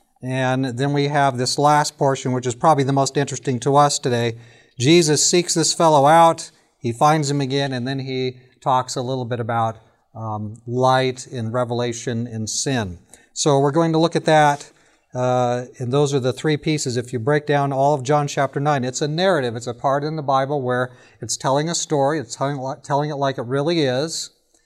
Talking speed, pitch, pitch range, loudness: 205 wpm, 135 Hz, 125-150 Hz, -20 LUFS